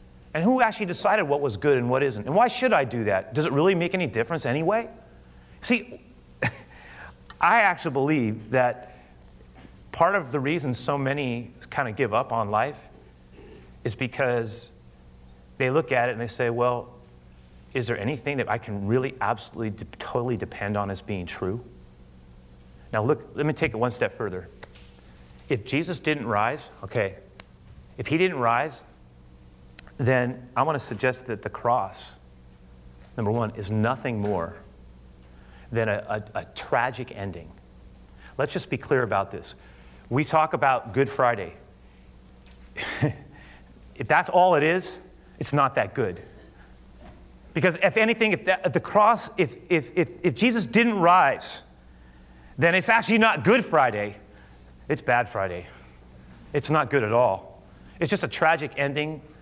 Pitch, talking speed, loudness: 120 Hz, 155 wpm, -24 LUFS